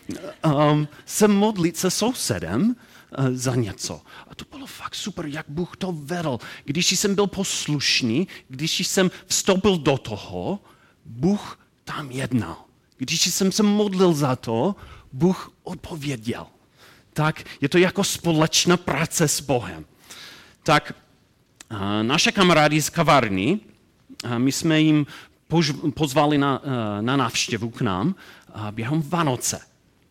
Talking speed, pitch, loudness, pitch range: 130 wpm, 150 Hz, -22 LUFS, 125-180 Hz